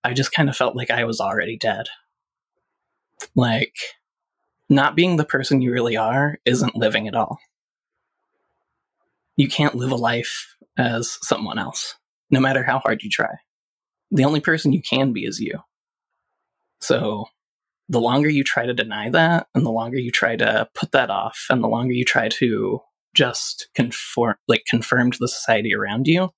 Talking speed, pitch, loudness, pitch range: 175 wpm, 135 Hz, -20 LUFS, 120-150 Hz